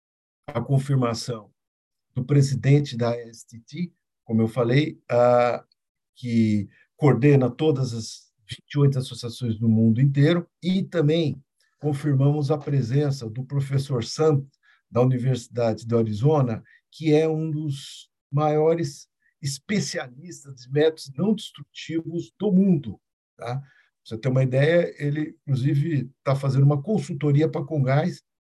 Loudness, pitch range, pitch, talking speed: -23 LUFS, 120-155 Hz, 140 Hz, 120 wpm